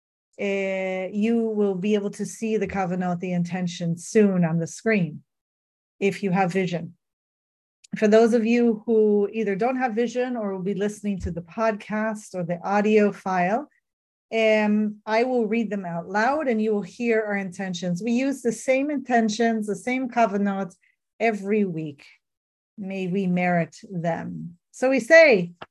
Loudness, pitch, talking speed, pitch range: -23 LUFS, 205 Hz, 165 wpm, 180-225 Hz